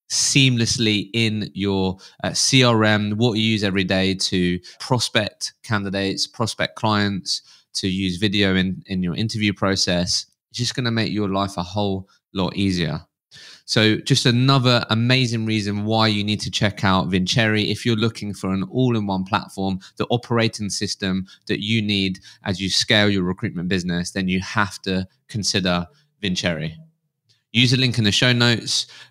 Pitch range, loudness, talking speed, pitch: 95-115 Hz, -20 LUFS, 165 wpm, 105 Hz